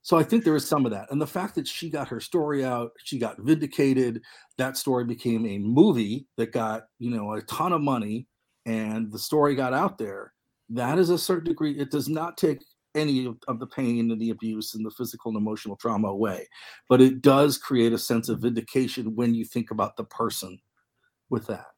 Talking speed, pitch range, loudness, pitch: 220 wpm, 115-145 Hz, -26 LUFS, 125 Hz